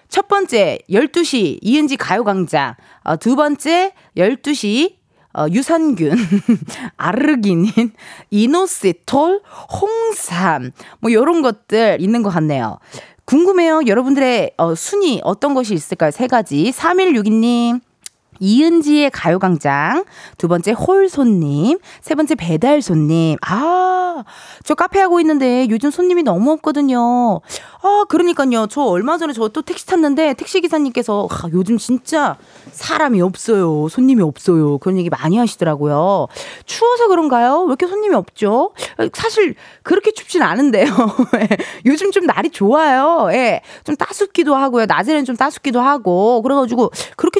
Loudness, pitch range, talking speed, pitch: -15 LUFS, 205-330 Hz, 280 characters per minute, 255 Hz